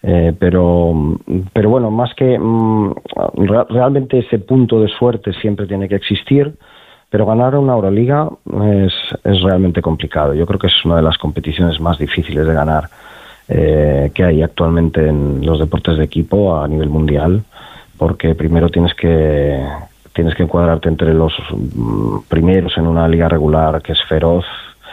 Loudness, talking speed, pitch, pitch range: -14 LUFS, 155 wpm, 85 Hz, 80-100 Hz